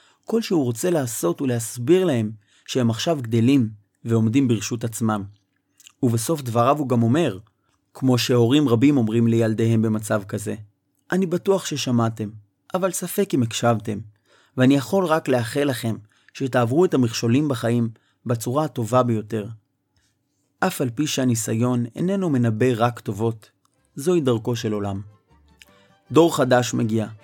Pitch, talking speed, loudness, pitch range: 120 Hz, 130 wpm, -21 LUFS, 110-140 Hz